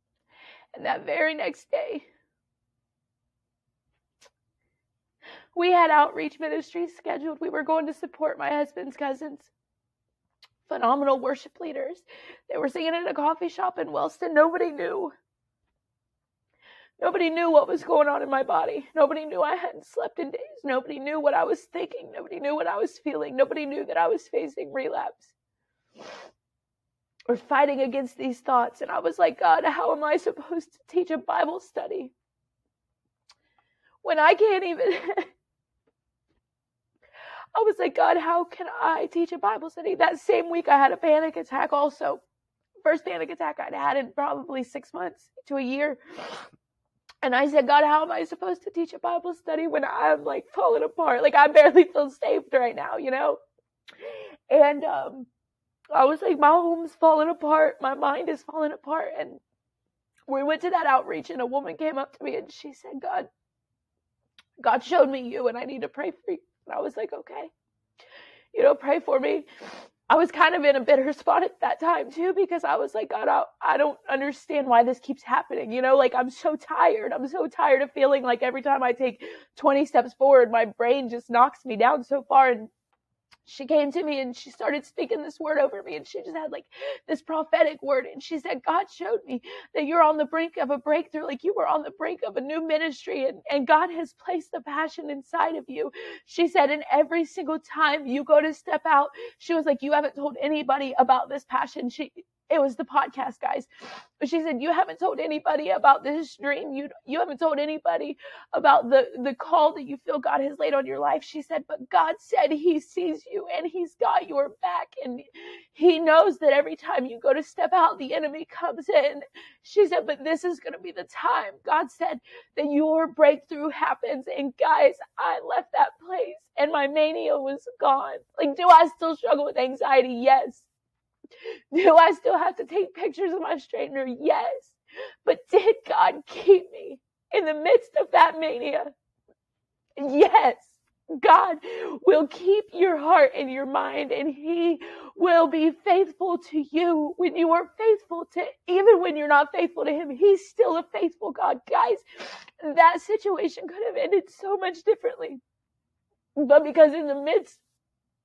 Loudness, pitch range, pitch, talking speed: -24 LUFS, 280-350 Hz, 310 Hz, 190 wpm